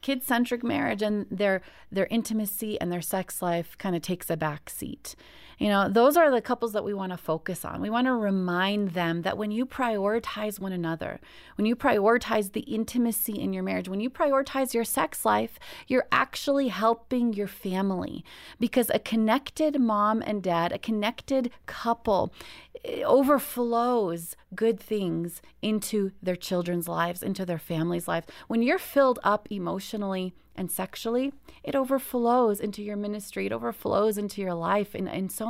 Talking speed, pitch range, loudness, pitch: 165 wpm, 185-240 Hz, -27 LUFS, 210 Hz